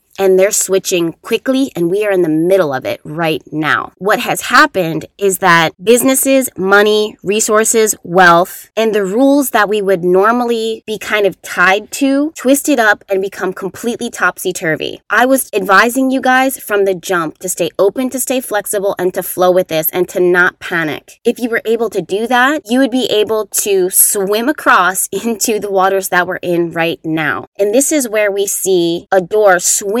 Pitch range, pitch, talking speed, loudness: 185-230 Hz, 200 Hz, 190 wpm, -13 LUFS